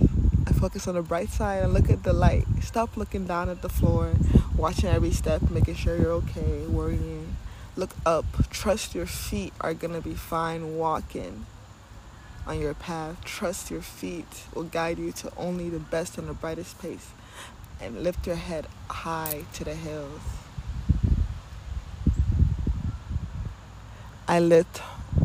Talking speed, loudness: 150 wpm, -28 LUFS